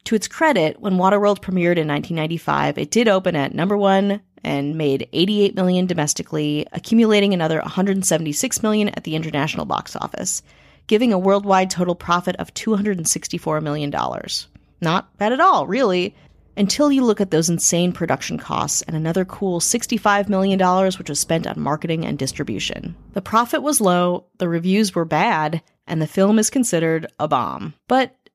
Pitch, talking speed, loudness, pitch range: 180 Hz, 165 wpm, -19 LUFS, 160-205 Hz